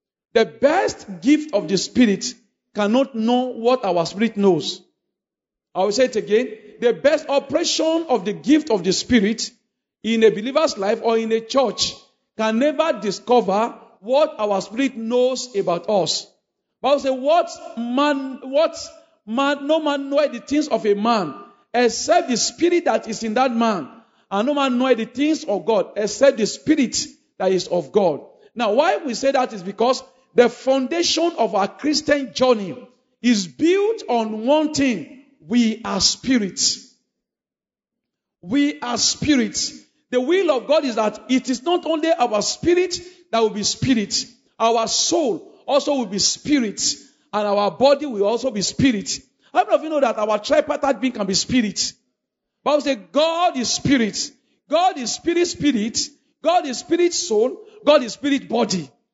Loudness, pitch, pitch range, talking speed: -20 LUFS, 255 Hz, 220-295 Hz, 170 wpm